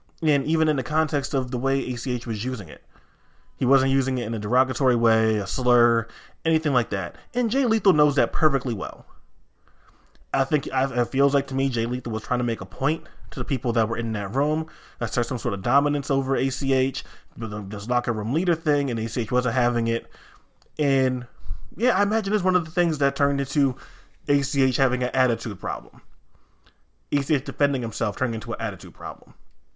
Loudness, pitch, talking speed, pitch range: -24 LUFS, 130 Hz, 200 wpm, 115-145 Hz